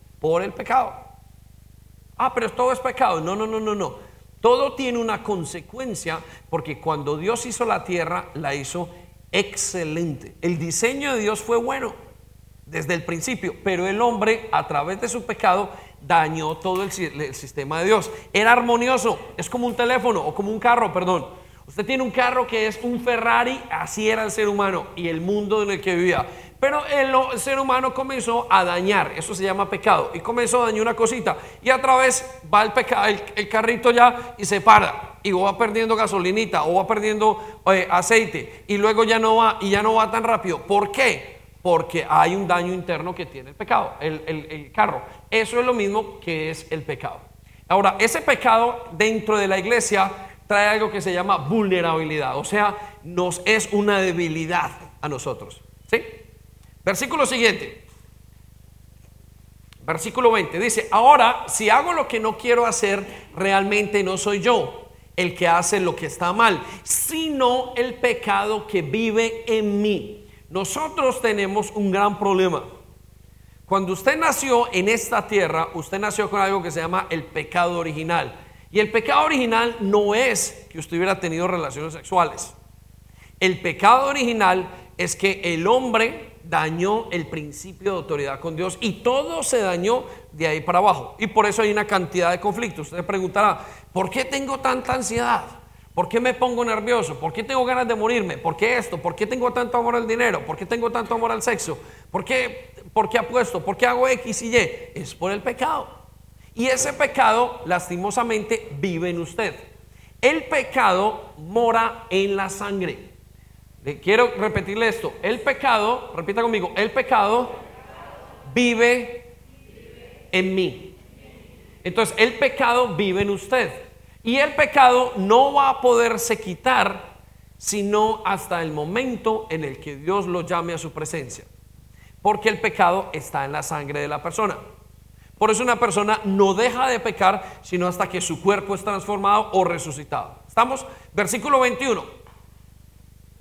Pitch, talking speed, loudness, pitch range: 205 Hz, 170 wpm, -21 LUFS, 175-235 Hz